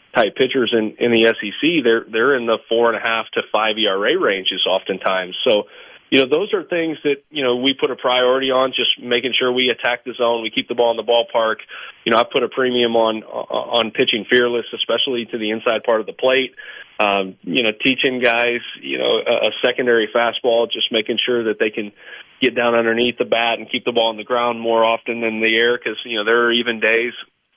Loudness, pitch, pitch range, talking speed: -17 LUFS, 120 Hz, 115-130 Hz, 230 wpm